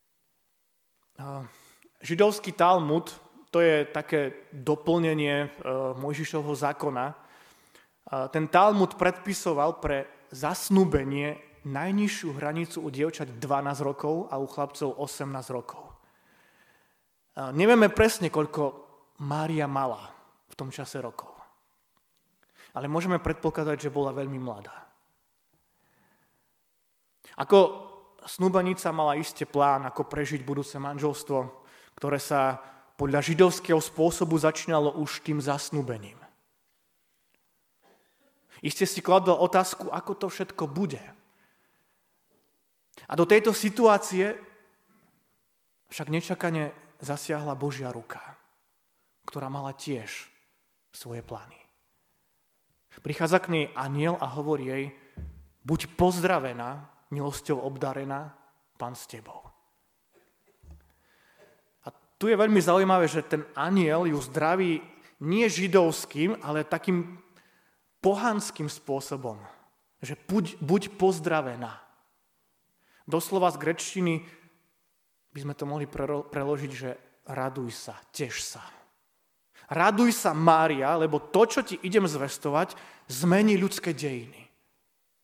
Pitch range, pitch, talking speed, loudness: 140-180 Hz, 150 Hz, 100 wpm, -27 LUFS